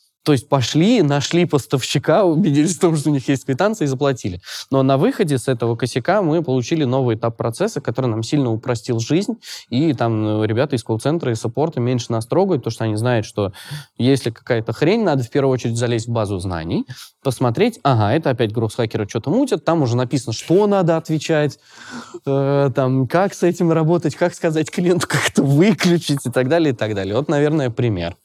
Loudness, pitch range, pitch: -18 LUFS, 120-155 Hz, 135 Hz